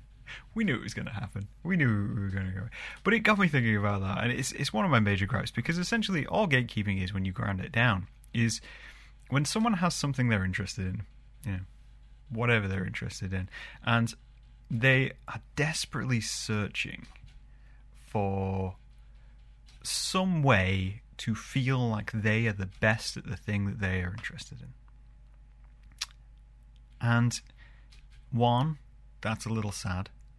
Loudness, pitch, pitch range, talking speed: -30 LUFS, 115 Hz, 100-130 Hz, 160 wpm